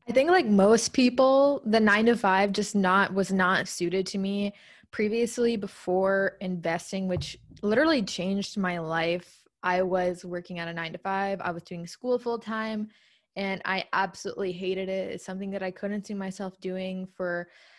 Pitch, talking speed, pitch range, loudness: 195 Hz, 175 wpm, 185-210 Hz, -27 LUFS